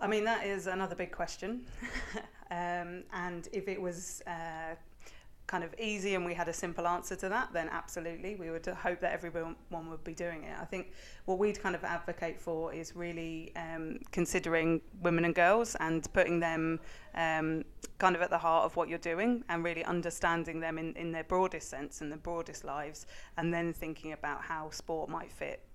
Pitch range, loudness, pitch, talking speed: 165-185 Hz, -35 LUFS, 170 Hz, 195 wpm